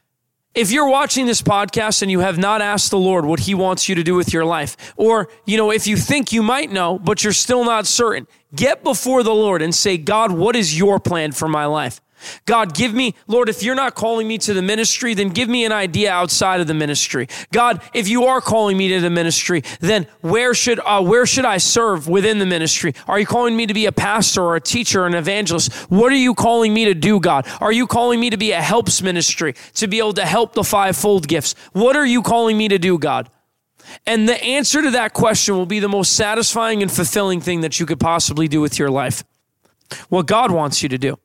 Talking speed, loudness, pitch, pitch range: 240 wpm, -16 LUFS, 205 Hz, 175-230 Hz